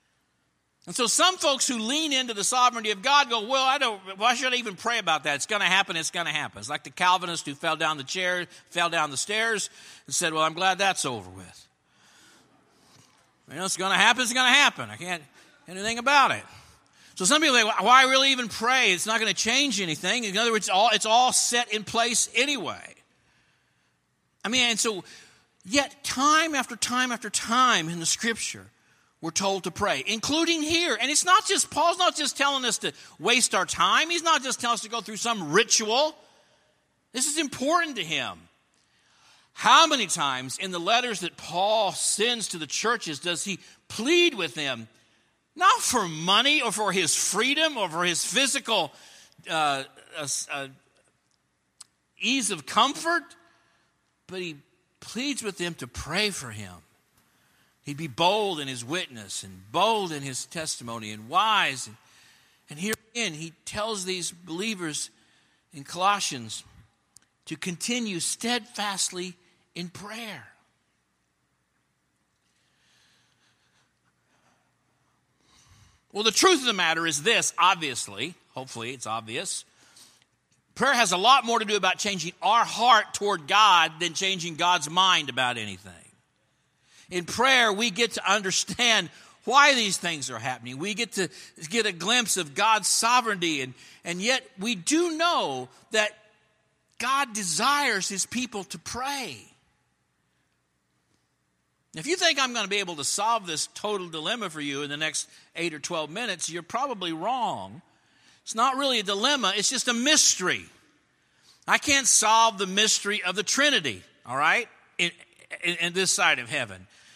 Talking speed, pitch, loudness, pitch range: 165 wpm, 200 Hz, -24 LUFS, 165-240 Hz